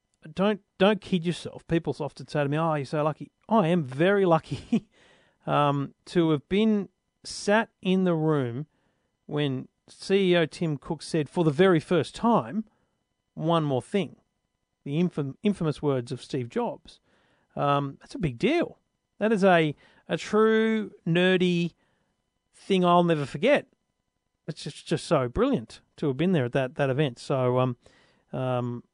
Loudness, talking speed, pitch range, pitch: -26 LUFS, 160 wpm, 145-190 Hz, 165 Hz